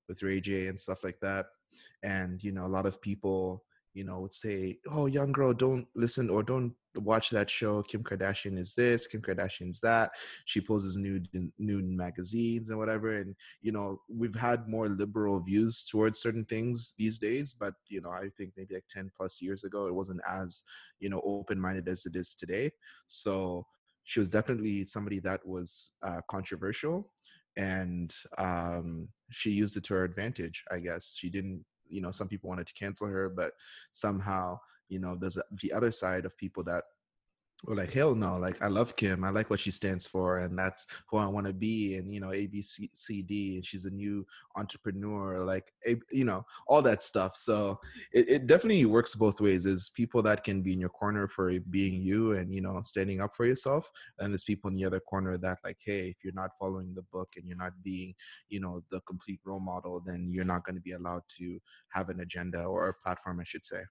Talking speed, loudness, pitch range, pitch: 210 wpm, -33 LUFS, 95-105 Hz, 95 Hz